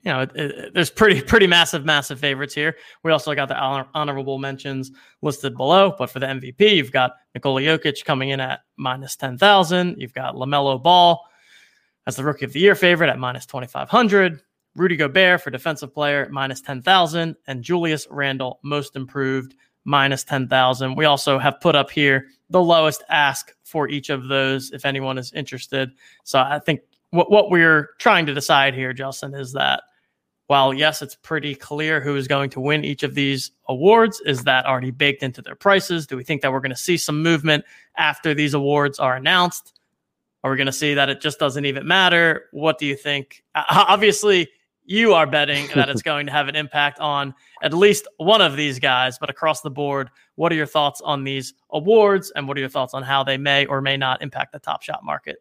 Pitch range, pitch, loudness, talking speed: 135-160 Hz, 145 Hz, -19 LUFS, 210 wpm